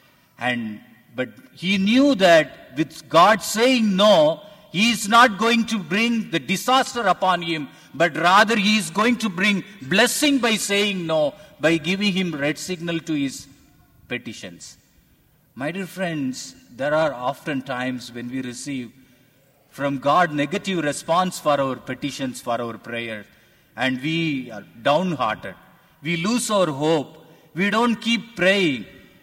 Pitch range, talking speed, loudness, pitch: 135-210 Hz, 145 wpm, -21 LUFS, 170 Hz